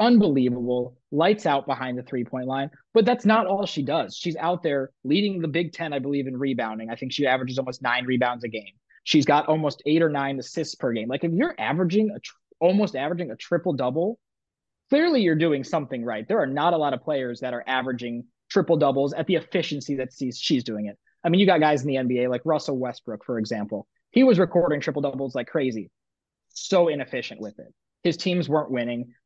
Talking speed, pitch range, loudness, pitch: 215 wpm, 125-170 Hz, -24 LUFS, 140 Hz